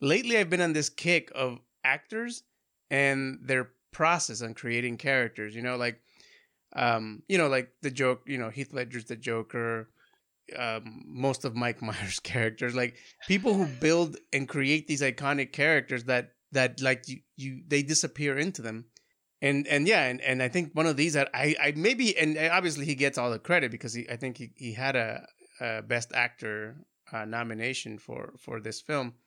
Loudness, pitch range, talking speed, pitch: -28 LUFS, 120-150 Hz, 185 wpm, 130 Hz